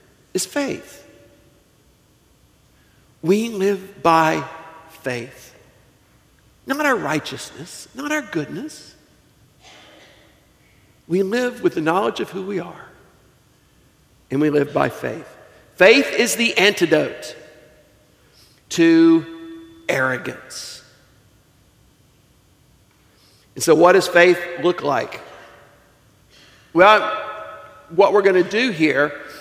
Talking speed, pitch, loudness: 90 wpm, 175 Hz, -18 LUFS